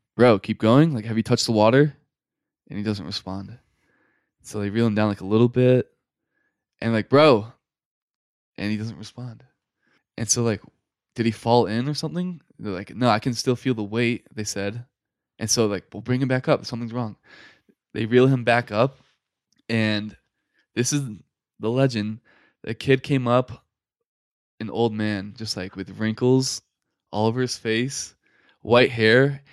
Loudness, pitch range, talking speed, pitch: -22 LUFS, 105-125 Hz, 175 wpm, 115 Hz